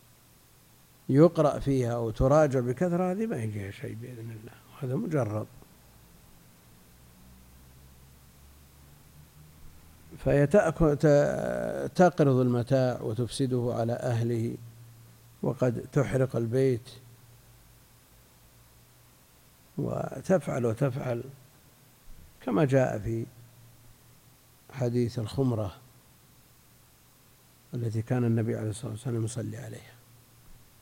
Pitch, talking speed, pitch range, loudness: 120 Hz, 70 wpm, 110-130 Hz, -28 LUFS